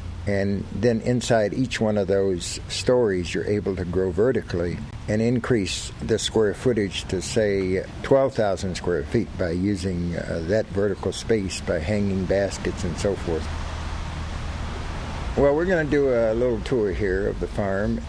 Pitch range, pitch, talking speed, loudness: 90-110 Hz, 100 Hz, 155 wpm, -24 LUFS